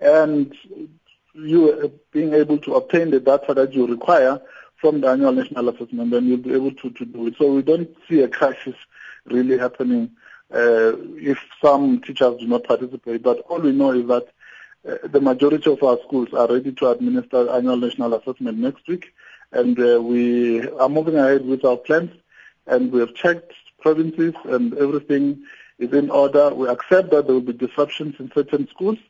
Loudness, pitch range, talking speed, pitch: -19 LUFS, 125-160 Hz, 185 wpm, 140 Hz